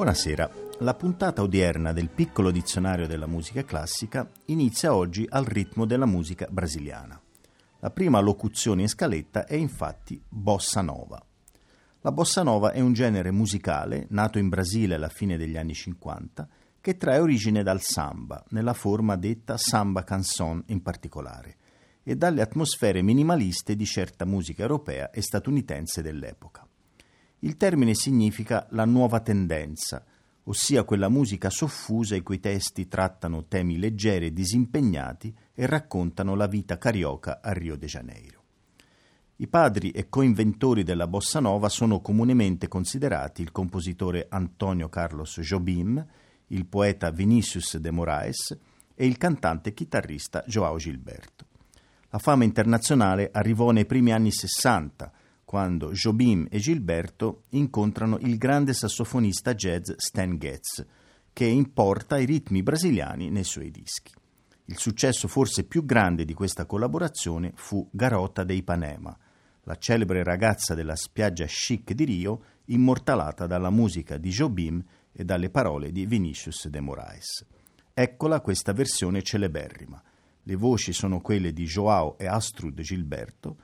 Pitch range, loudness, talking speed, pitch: 90-115 Hz, -26 LUFS, 135 wpm, 100 Hz